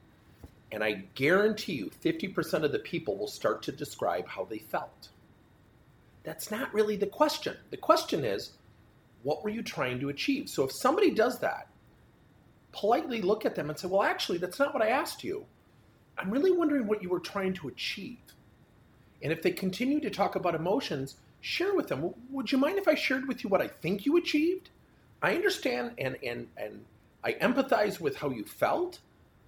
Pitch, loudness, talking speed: 210 Hz, -30 LUFS, 185 wpm